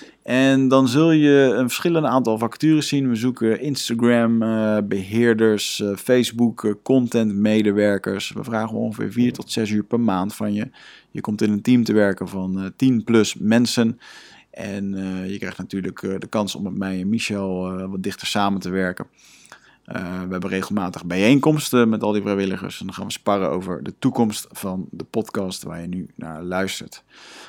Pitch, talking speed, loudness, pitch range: 105 Hz, 170 wpm, -21 LUFS, 95-120 Hz